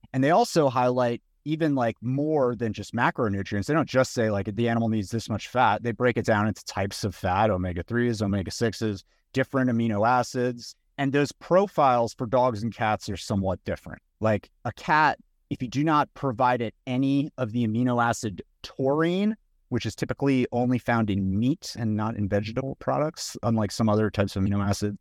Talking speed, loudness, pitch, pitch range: 190 wpm, -26 LUFS, 115 Hz, 105-130 Hz